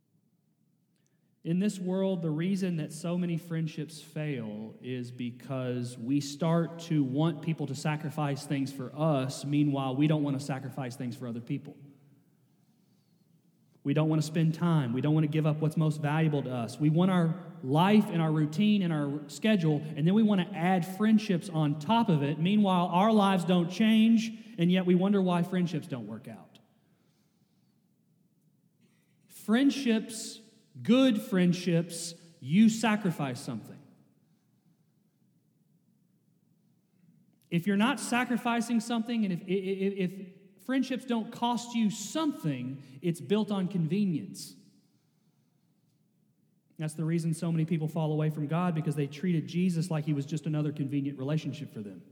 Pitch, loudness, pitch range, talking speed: 170 Hz, -29 LUFS, 150-190 Hz, 150 wpm